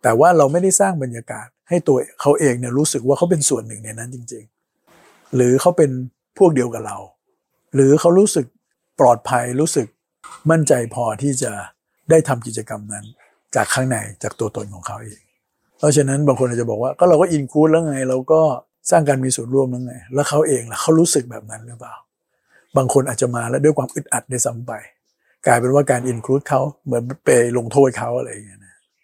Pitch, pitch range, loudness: 130 Hz, 120-150 Hz, -17 LUFS